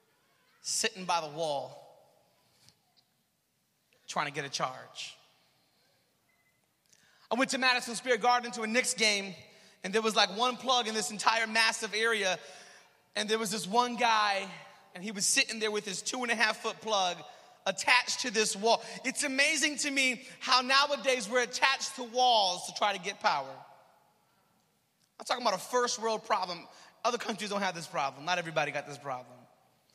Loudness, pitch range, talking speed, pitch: -29 LUFS, 195-245 Hz, 170 wpm, 220 Hz